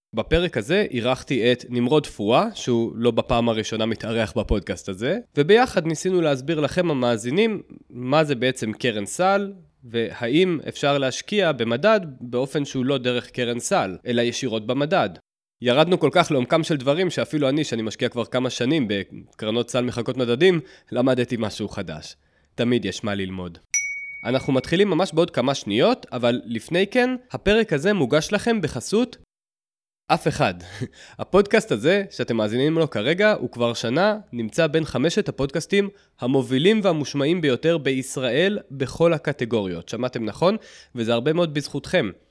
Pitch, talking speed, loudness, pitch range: 135 Hz, 145 wpm, -22 LUFS, 120-170 Hz